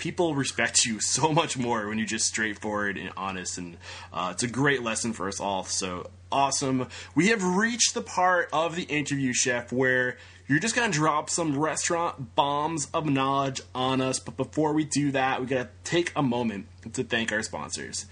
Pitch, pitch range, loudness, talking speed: 130 Hz, 105-150 Hz, -26 LUFS, 190 wpm